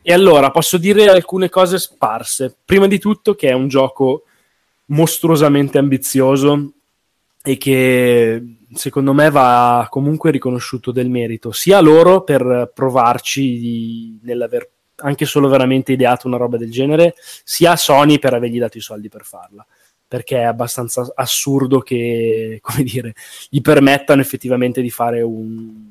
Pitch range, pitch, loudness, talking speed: 120-150 Hz, 130 Hz, -14 LUFS, 145 wpm